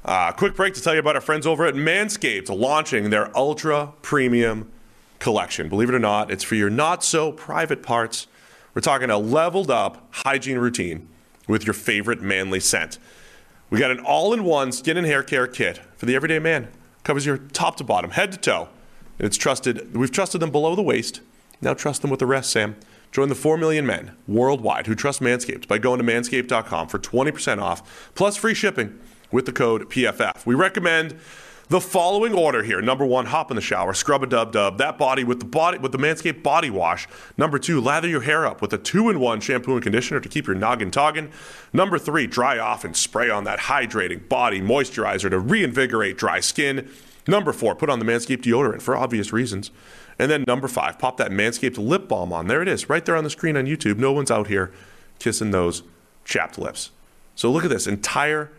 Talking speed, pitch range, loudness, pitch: 205 wpm, 110-155 Hz, -21 LUFS, 130 Hz